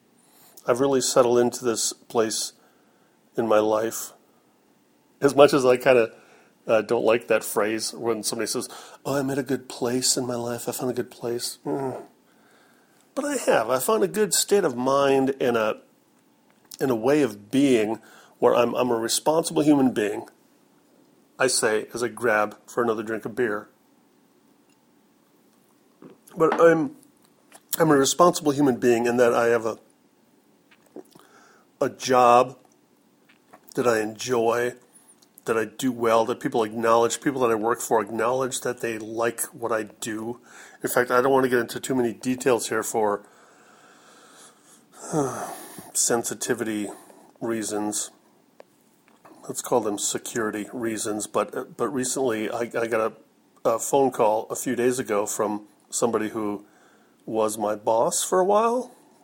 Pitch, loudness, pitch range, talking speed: 120 Hz, -23 LUFS, 110-135 Hz, 155 wpm